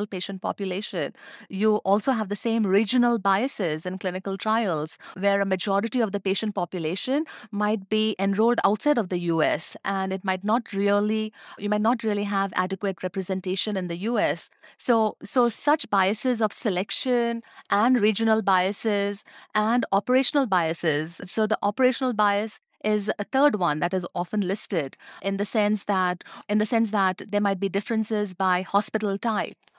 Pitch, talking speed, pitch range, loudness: 205 Hz, 160 wpm, 195-220 Hz, -25 LUFS